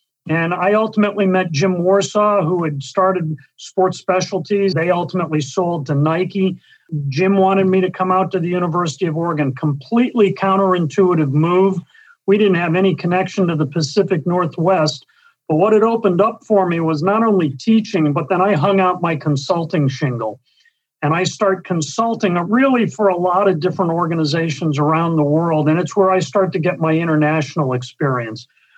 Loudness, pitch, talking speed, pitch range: -17 LUFS, 180 Hz, 170 wpm, 160-195 Hz